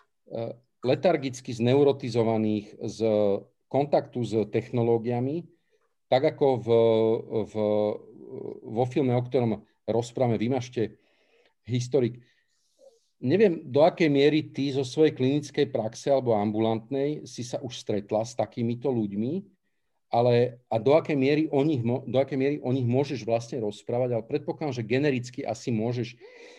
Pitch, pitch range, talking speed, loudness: 125 Hz, 115-145 Hz, 125 wpm, -26 LUFS